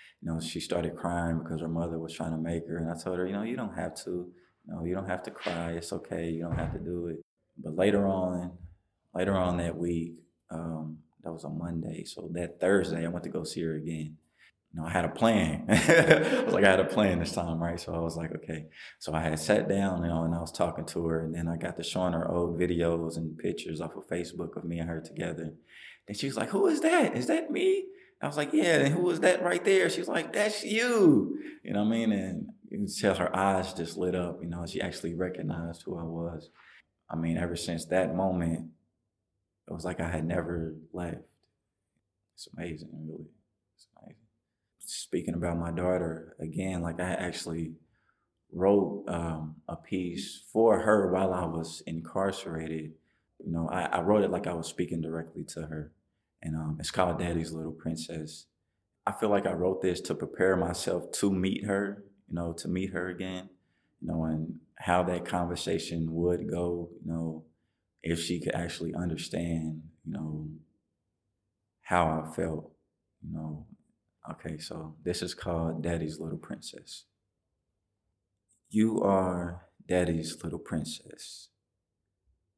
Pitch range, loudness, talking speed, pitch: 80-95 Hz, -31 LUFS, 195 wpm, 85 Hz